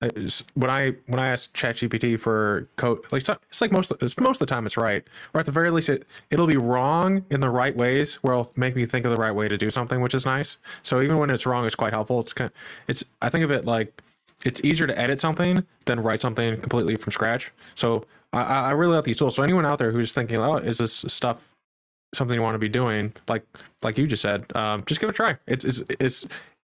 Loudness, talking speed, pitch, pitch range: -24 LUFS, 255 wpm, 125 Hz, 115-145 Hz